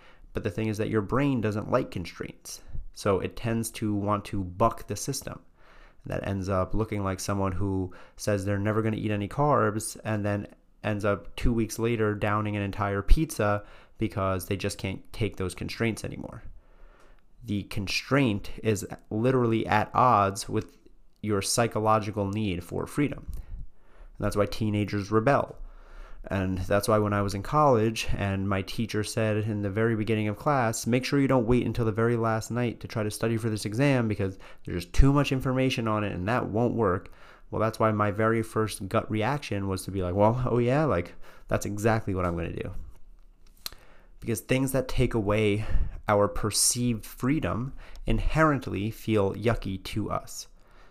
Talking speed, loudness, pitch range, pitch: 180 wpm, -28 LUFS, 100-115 Hz, 105 Hz